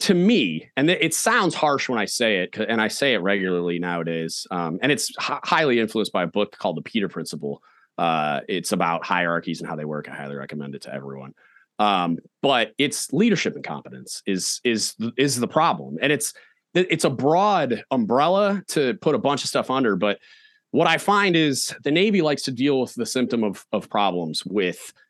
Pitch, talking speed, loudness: 115 Hz, 200 wpm, -22 LUFS